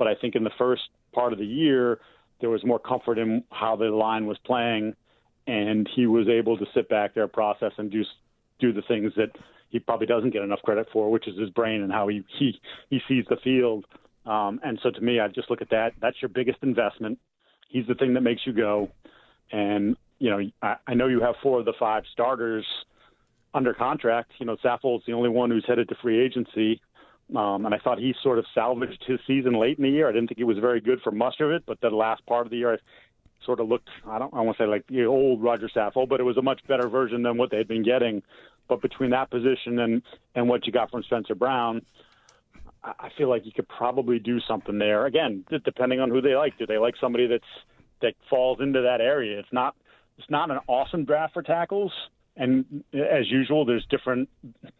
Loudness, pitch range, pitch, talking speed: -25 LUFS, 110-130 Hz, 120 Hz, 230 wpm